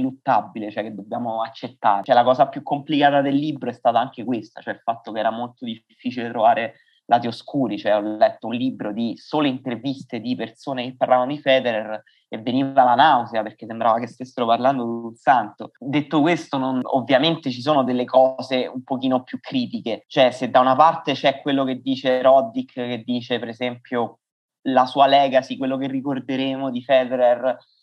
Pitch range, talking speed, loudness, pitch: 120-140 Hz, 185 wpm, -21 LUFS, 130 Hz